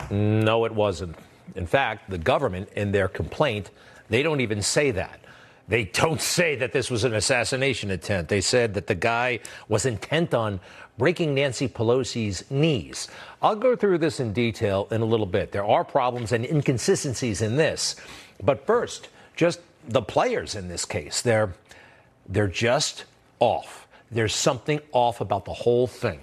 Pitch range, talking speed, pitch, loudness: 105-130 Hz, 165 wpm, 115 Hz, -24 LUFS